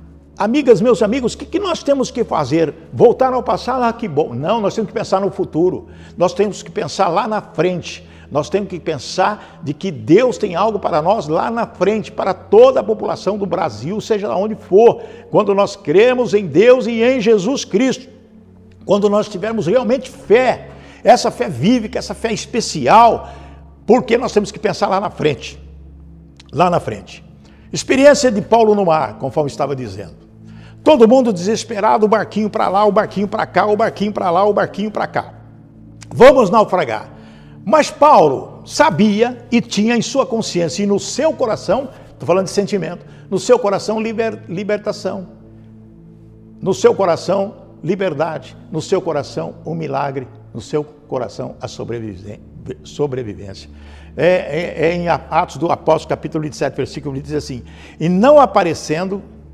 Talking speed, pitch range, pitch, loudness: 170 wpm, 150-225 Hz, 195 Hz, -16 LUFS